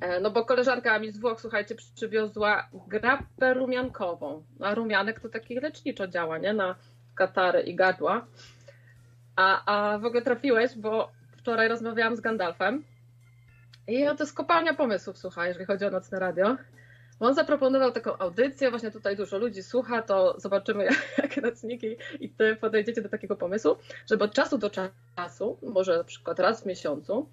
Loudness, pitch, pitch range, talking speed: -27 LUFS, 210 Hz, 185-240 Hz, 160 wpm